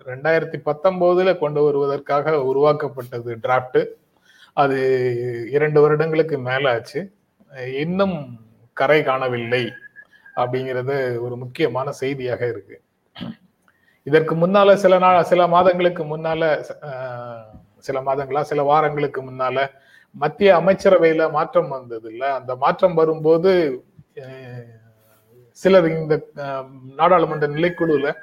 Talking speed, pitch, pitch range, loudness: 90 wpm, 145 Hz, 130-165 Hz, -19 LUFS